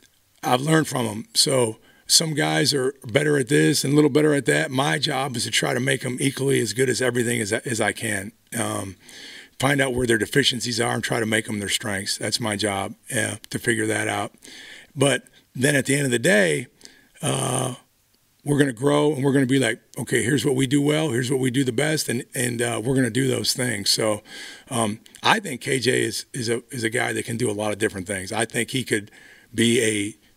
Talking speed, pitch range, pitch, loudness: 235 wpm, 110-135 Hz, 125 Hz, -22 LUFS